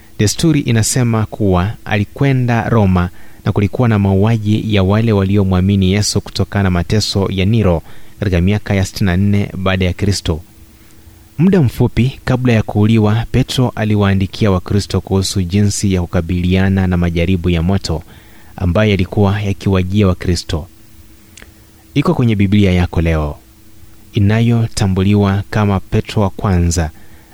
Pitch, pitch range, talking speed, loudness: 100 Hz, 95-110 Hz, 120 wpm, -14 LUFS